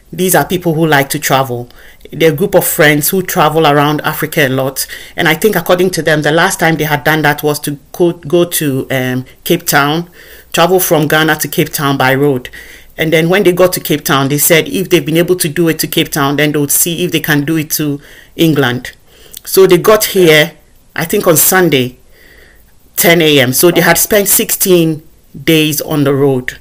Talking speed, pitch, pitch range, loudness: 215 wpm, 155 Hz, 145-175 Hz, -10 LUFS